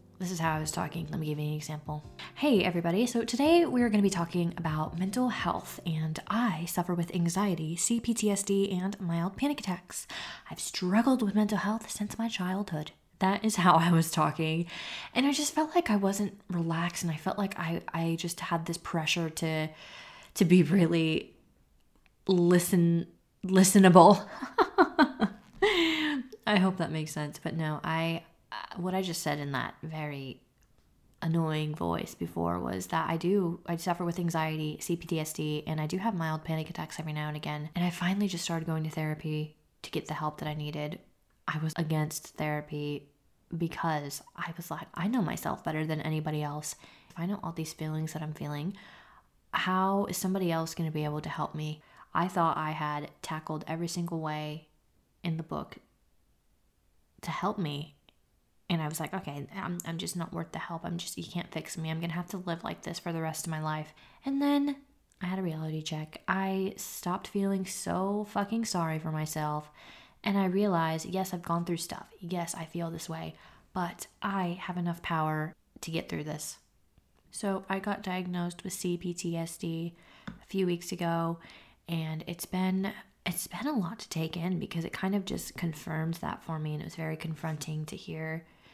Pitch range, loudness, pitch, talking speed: 155-190 Hz, -31 LUFS, 170 Hz, 190 wpm